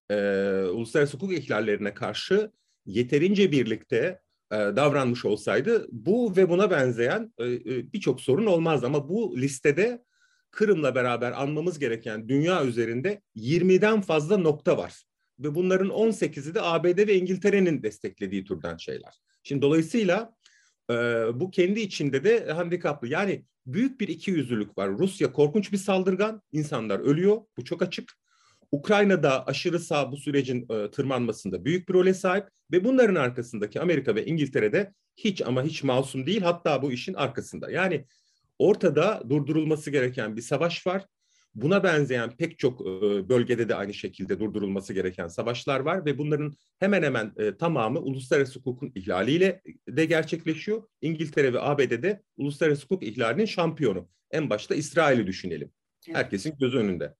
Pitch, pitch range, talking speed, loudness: 155 Hz, 125-195 Hz, 140 wpm, -26 LUFS